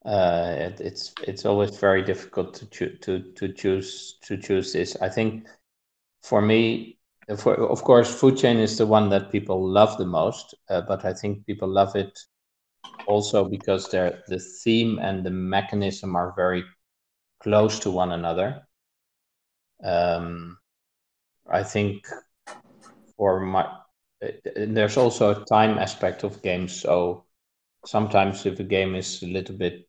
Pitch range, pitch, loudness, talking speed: 90-105 Hz, 95 Hz, -24 LUFS, 145 wpm